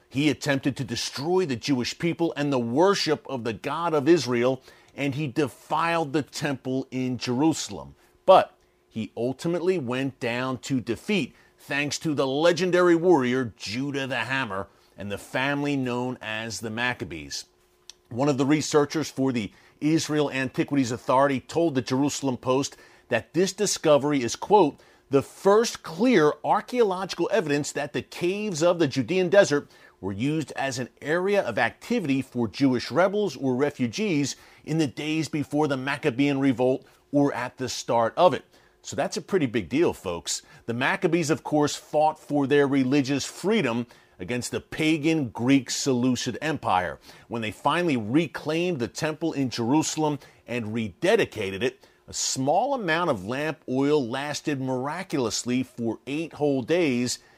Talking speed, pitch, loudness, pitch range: 150 wpm, 140 Hz, -25 LUFS, 125-155 Hz